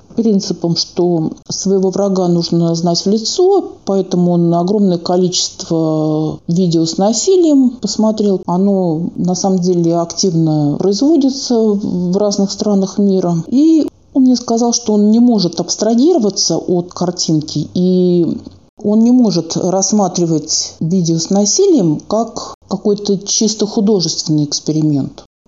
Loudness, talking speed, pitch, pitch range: -13 LUFS, 120 wpm, 190 Hz, 170-215 Hz